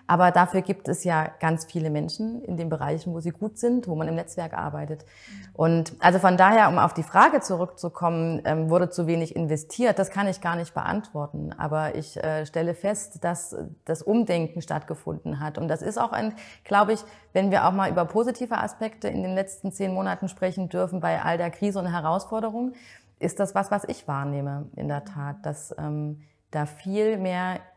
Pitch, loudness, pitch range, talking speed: 175 Hz, -25 LUFS, 160-200 Hz, 195 wpm